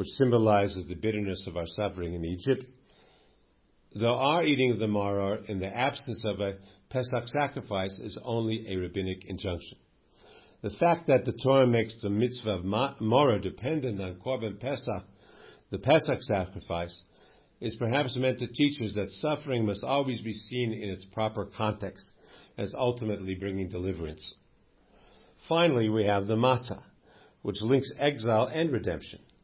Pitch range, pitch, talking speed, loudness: 100-130 Hz, 110 Hz, 155 wpm, -29 LUFS